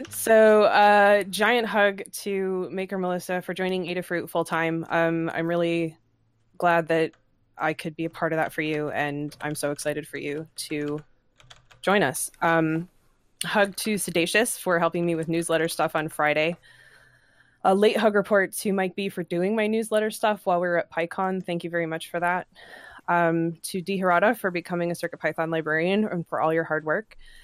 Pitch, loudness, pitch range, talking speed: 170 Hz, -24 LUFS, 160-190 Hz, 190 wpm